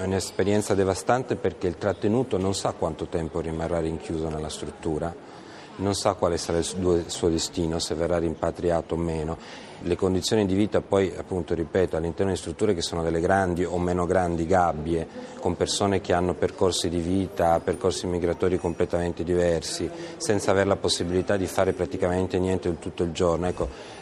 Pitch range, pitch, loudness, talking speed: 85-95 Hz, 90 Hz, -26 LUFS, 165 wpm